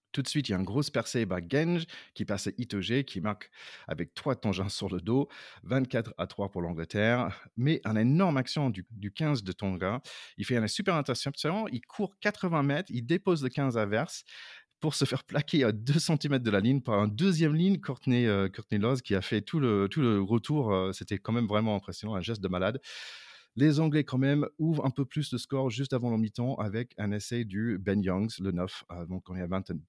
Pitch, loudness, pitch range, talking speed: 120 Hz, -30 LUFS, 100-140 Hz, 235 wpm